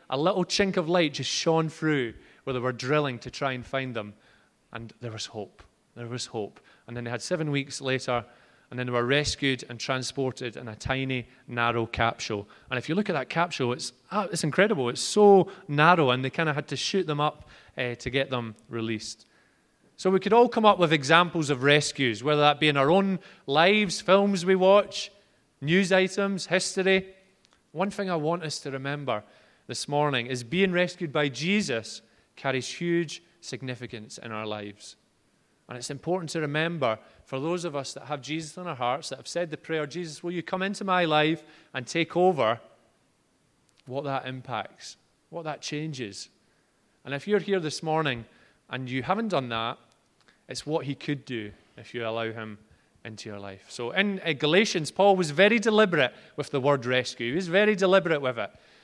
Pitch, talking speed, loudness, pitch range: 145 Hz, 195 wpm, -26 LUFS, 125-180 Hz